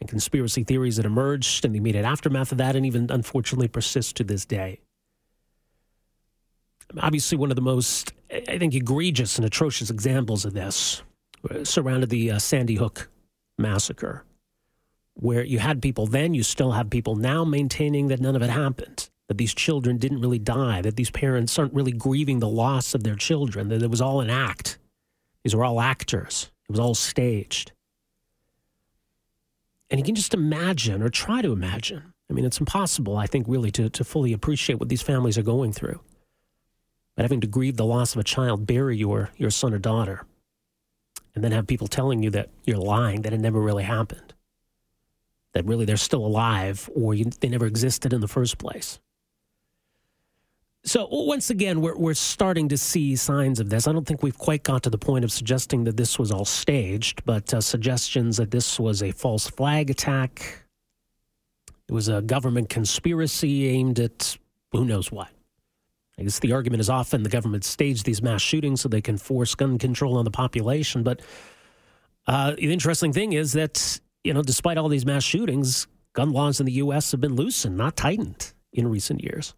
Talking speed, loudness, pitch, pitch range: 185 wpm, -24 LUFS, 125 Hz, 110-140 Hz